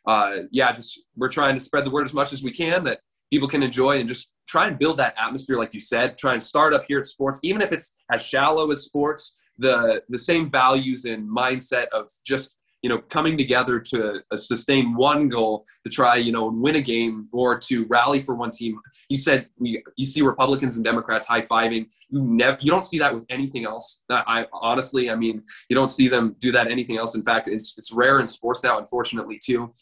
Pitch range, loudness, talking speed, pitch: 115-140 Hz, -22 LUFS, 230 wpm, 130 Hz